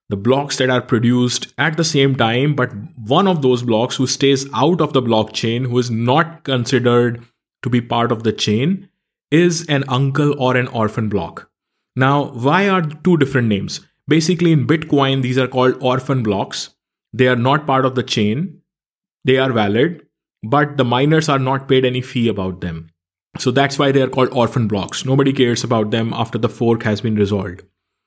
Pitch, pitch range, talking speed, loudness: 130 Hz, 115-140 Hz, 190 wpm, -17 LUFS